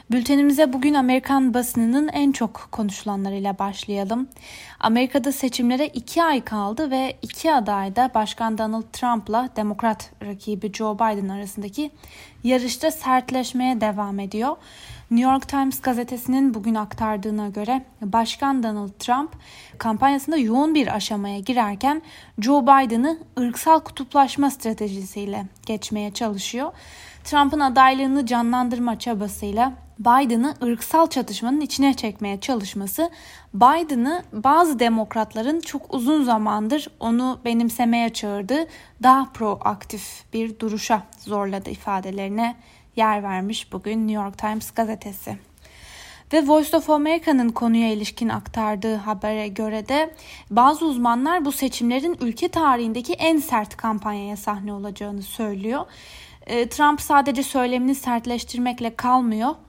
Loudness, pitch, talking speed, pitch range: -22 LUFS, 240 Hz, 110 wpm, 215-275 Hz